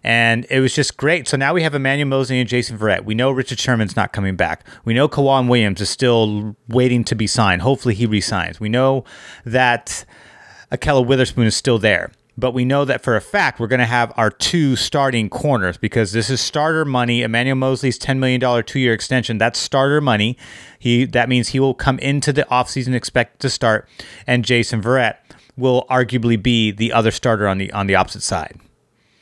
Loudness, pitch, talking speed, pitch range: -17 LUFS, 125 Hz, 205 wpm, 115-130 Hz